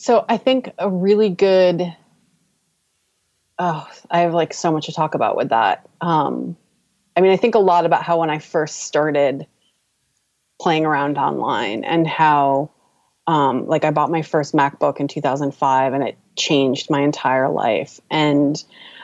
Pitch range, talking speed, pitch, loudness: 140-170 Hz, 165 wpm, 155 Hz, -18 LUFS